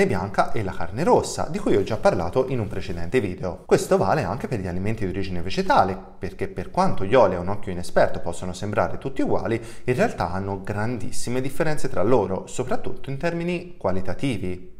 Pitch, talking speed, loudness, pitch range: 100 Hz, 190 wpm, -24 LUFS, 90-130 Hz